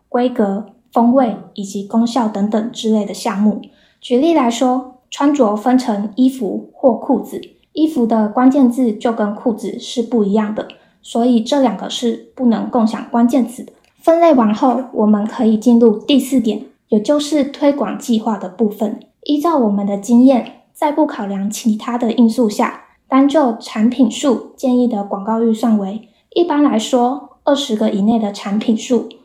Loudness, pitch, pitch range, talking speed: -15 LUFS, 235 Hz, 220-260 Hz, 250 characters per minute